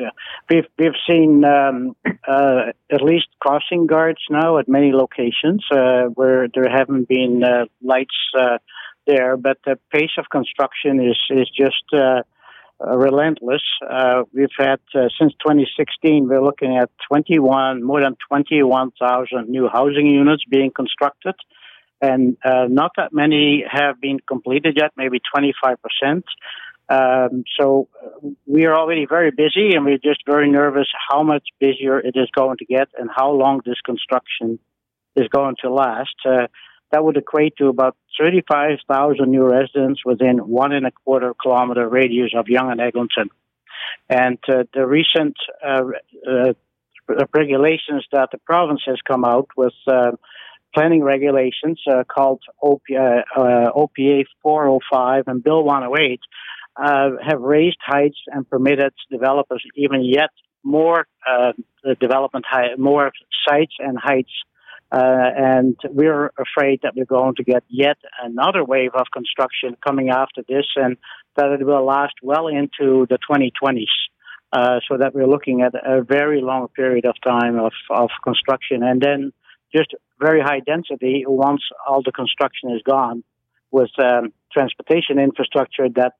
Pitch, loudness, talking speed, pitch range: 135 Hz, -17 LUFS, 145 wpm, 130-145 Hz